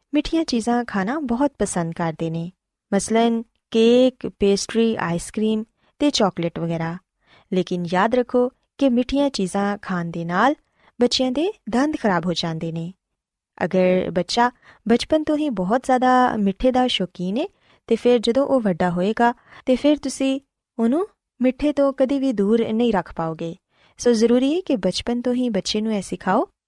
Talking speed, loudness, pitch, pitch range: 160 wpm, -21 LUFS, 230 Hz, 185-260 Hz